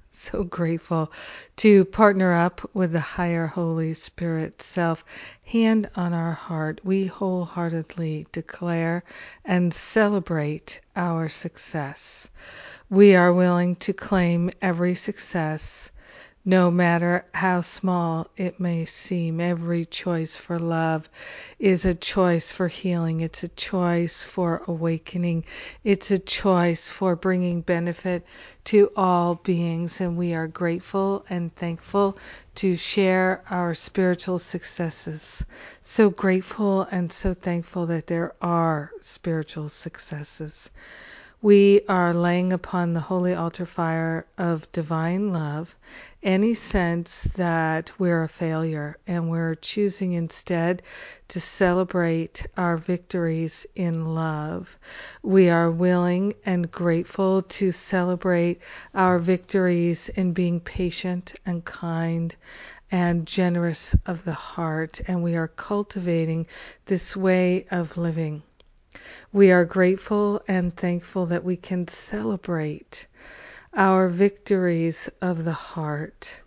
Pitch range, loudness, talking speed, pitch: 165-185 Hz, -24 LUFS, 115 wpm, 175 Hz